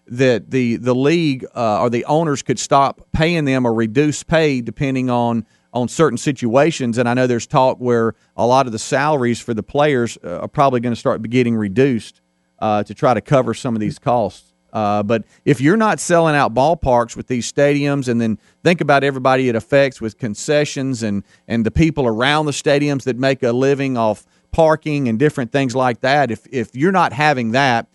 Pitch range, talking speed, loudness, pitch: 115-145 Hz, 200 wpm, -17 LUFS, 130 Hz